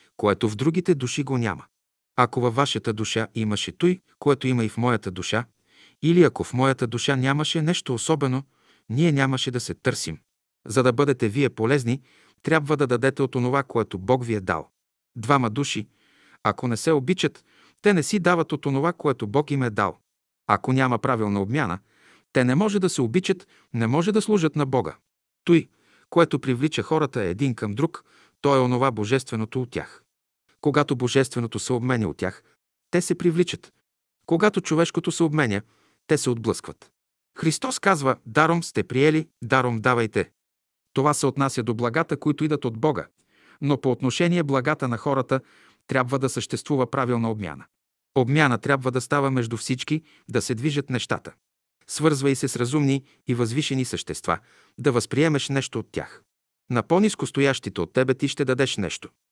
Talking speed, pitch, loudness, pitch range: 170 wpm, 135 Hz, -23 LUFS, 120-150 Hz